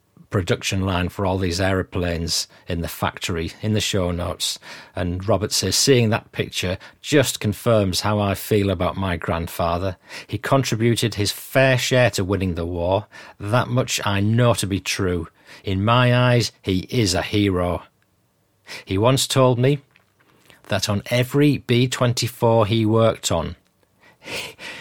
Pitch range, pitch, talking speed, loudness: 90-120 Hz, 100 Hz, 150 wpm, -21 LUFS